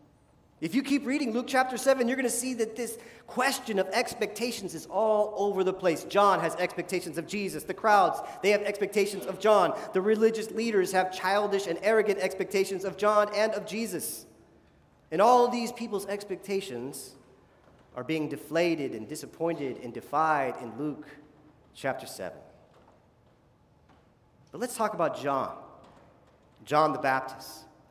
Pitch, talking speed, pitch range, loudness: 195 Hz, 150 wpm, 160-220 Hz, -28 LUFS